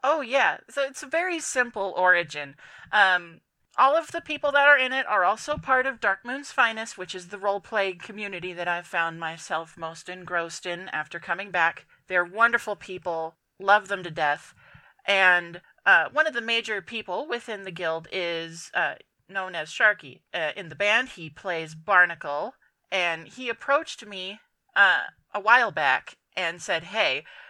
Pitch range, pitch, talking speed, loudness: 170-235 Hz, 190 Hz, 170 wpm, -25 LUFS